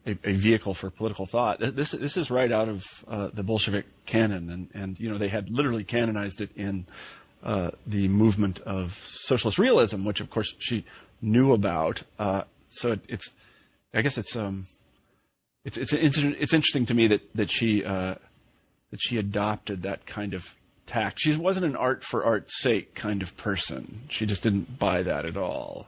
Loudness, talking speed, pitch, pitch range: -27 LUFS, 190 wpm, 105 Hz, 95-115 Hz